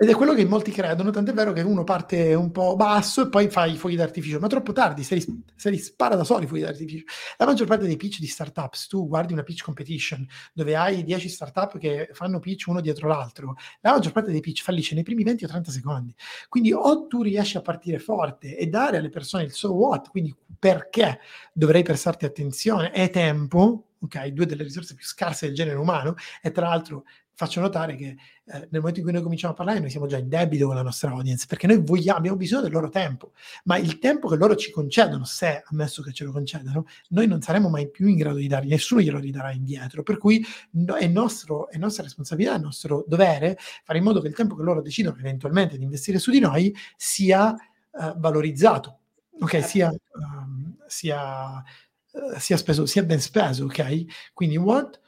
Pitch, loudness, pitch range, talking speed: 170 Hz, -23 LUFS, 150-200 Hz, 215 wpm